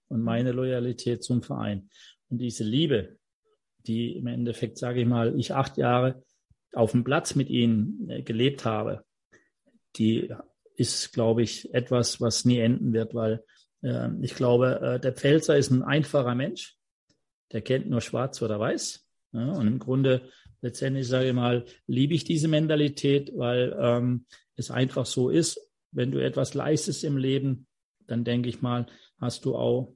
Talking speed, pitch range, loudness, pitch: 160 wpm, 120-135 Hz, -27 LUFS, 125 Hz